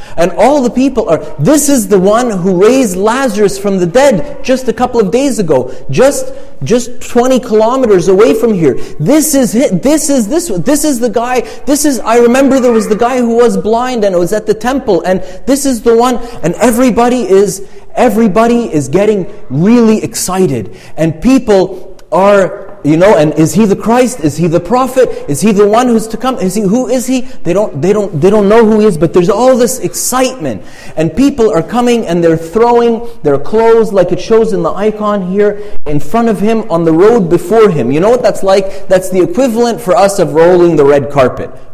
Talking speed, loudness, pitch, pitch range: 210 wpm, -9 LUFS, 220 Hz, 185-245 Hz